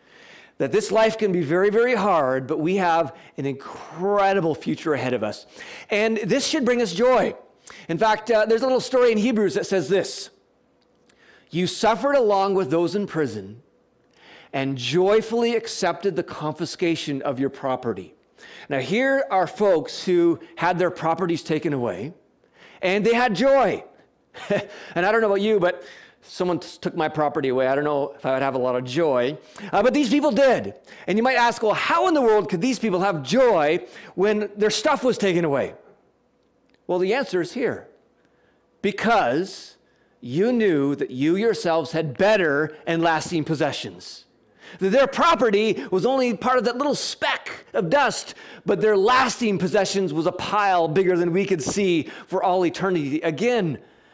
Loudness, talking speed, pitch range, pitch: -22 LUFS, 175 wpm, 165-225 Hz, 190 Hz